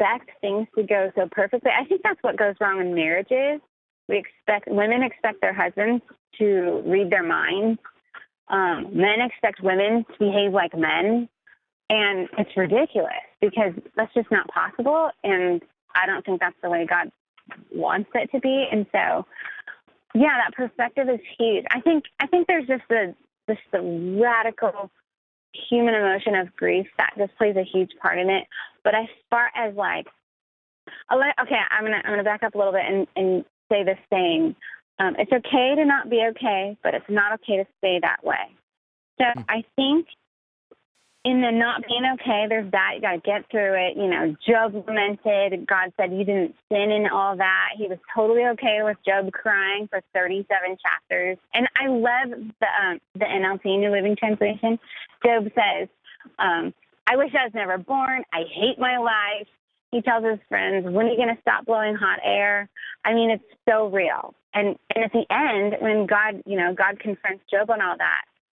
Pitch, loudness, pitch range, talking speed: 215 Hz, -22 LUFS, 195-240 Hz, 185 wpm